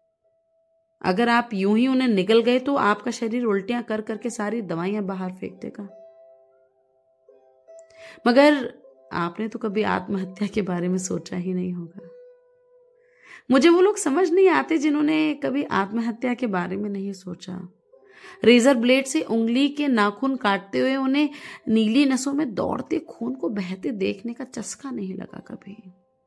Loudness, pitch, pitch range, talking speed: -22 LUFS, 235 Hz, 195-285 Hz, 150 wpm